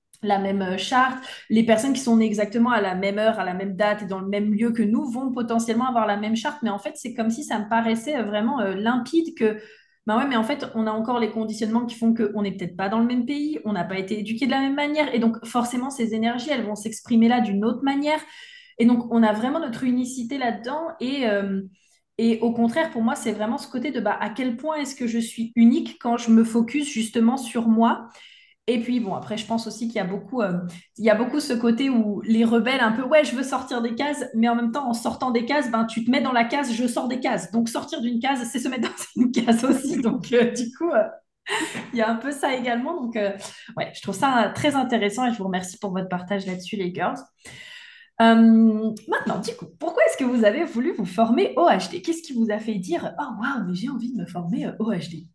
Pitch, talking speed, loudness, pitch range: 235 Hz, 255 wpm, -23 LUFS, 220-265 Hz